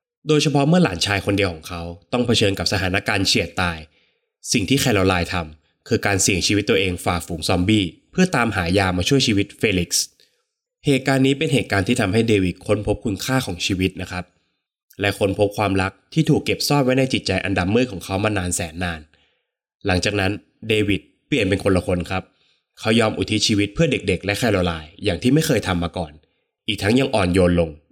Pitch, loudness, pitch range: 100 Hz, -20 LUFS, 90-120 Hz